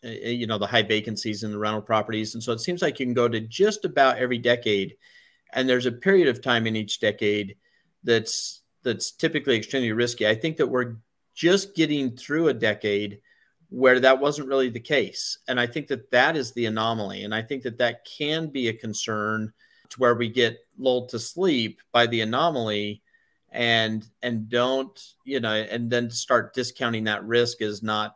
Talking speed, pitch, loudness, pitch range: 195 wpm, 120 Hz, -24 LUFS, 110-130 Hz